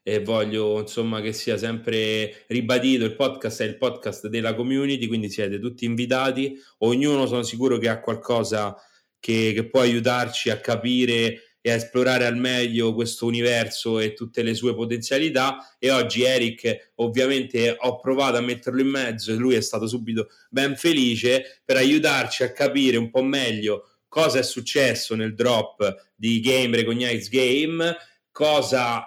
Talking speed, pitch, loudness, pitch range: 155 wpm, 120 Hz, -23 LUFS, 115-130 Hz